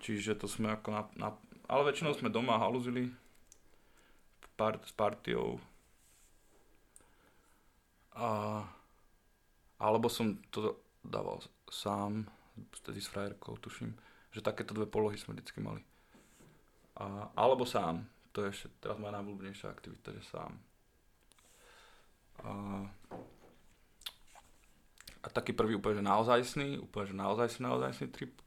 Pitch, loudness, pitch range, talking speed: 105 Hz, -37 LUFS, 100-110 Hz, 115 wpm